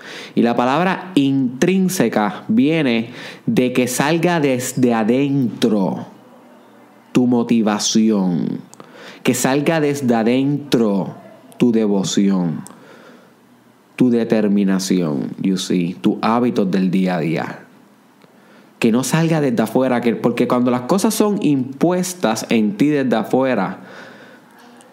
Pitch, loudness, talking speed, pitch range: 125 Hz, -17 LUFS, 105 wpm, 110-150 Hz